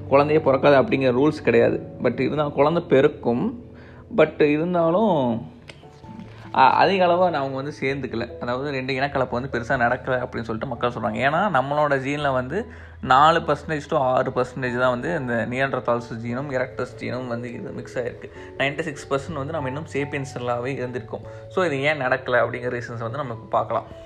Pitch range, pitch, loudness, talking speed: 120-145 Hz, 130 Hz, -22 LUFS, 155 wpm